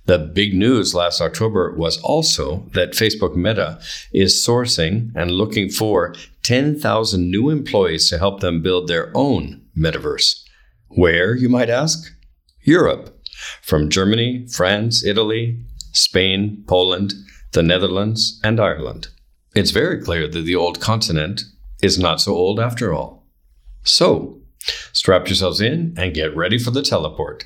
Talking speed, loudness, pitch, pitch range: 140 wpm, -17 LUFS, 100 Hz, 85-115 Hz